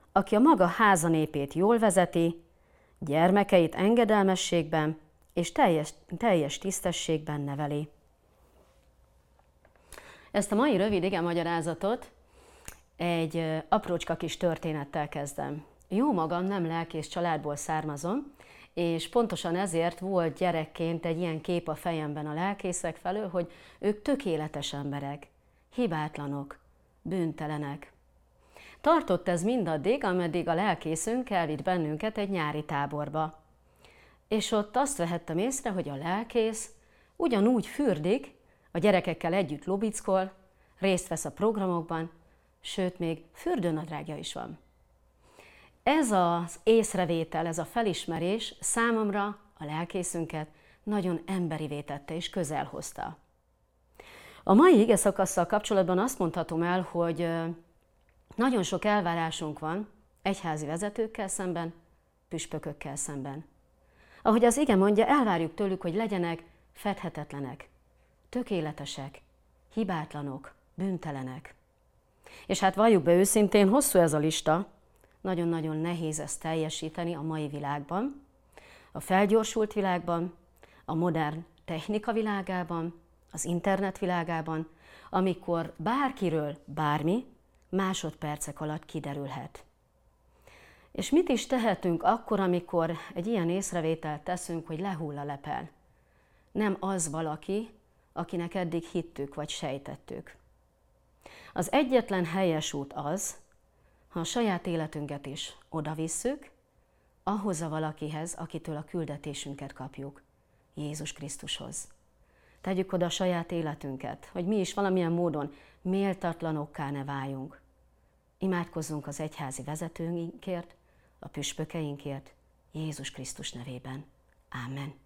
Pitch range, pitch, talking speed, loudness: 150-190 Hz, 170 Hz, 110 wpm, -30 LUFS